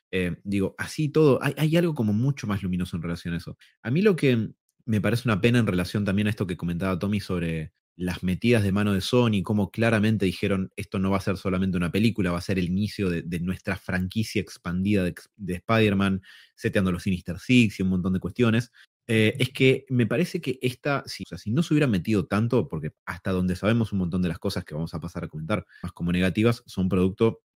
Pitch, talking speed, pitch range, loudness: 100 Hz, 235 wpm, 90-115 Hz, -25 LUFS